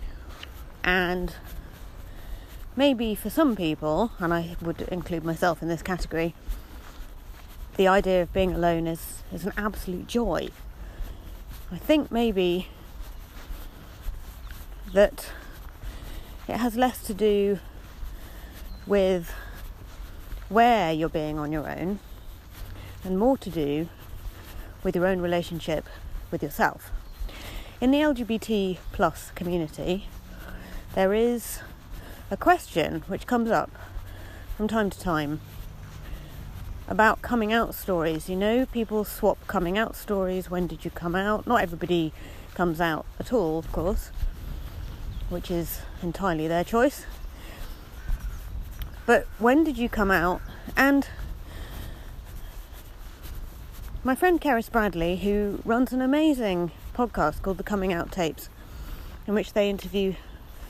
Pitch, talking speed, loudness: 165 Hz, 120 wpm, -26 LUFS